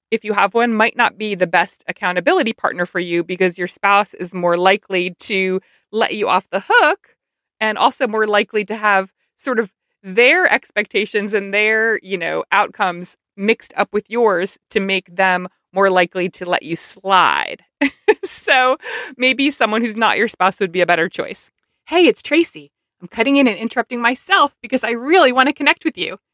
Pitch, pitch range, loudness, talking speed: 210 Hz, 185-240 Hz, -16 LUFS, 185 wpm